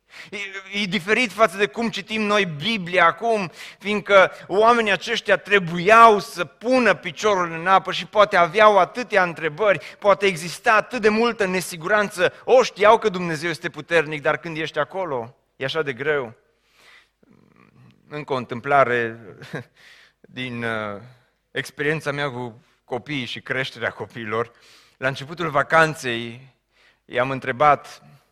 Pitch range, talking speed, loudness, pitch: 140-205 Hz, 125 wpm, -20 LUFS, 175 Hz